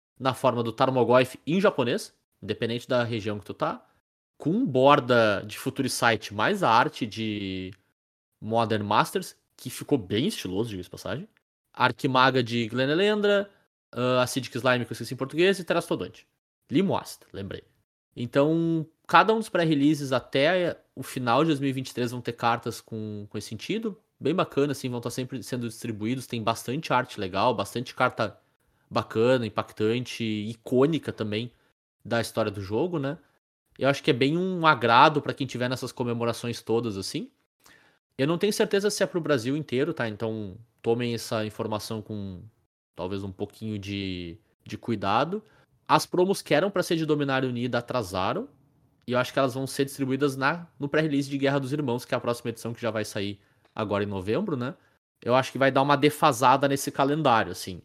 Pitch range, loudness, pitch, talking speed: 110-140 Hz, -26 LUFS, 125 Hz, 175 wpm